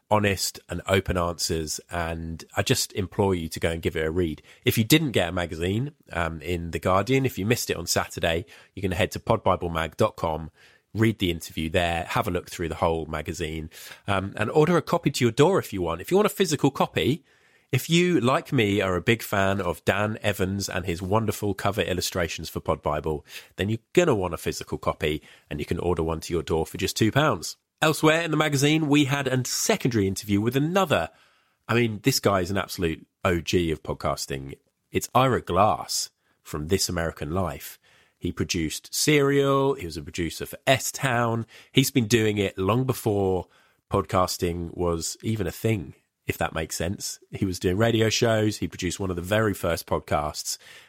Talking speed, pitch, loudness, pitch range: 200 wpm, 95 Hz, -25 LUFS, 85-120 Hz